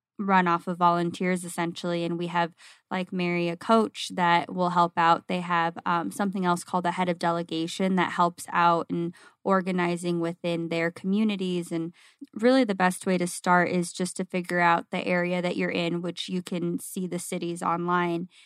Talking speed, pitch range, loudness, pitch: 190 wpm, 170-185 Hz, -26 LUFS, 175 Hz